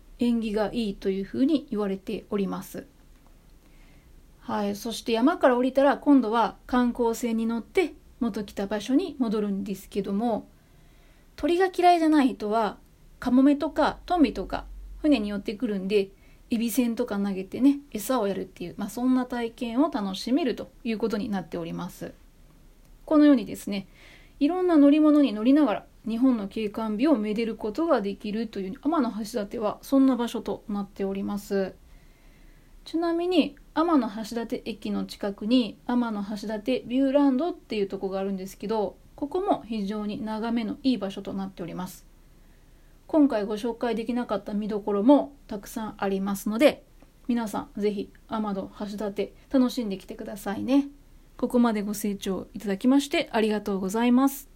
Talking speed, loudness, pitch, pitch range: 345 characters per minute, -26 LUFS, 230 Hz, 205-270 Hz